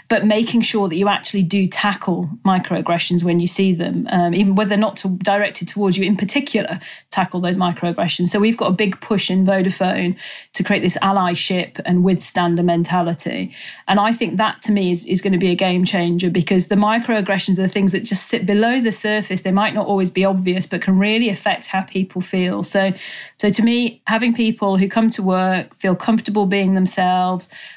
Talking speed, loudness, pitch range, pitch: 205 wpm, -17 LUFS, 180-210 Hz, 195 Hz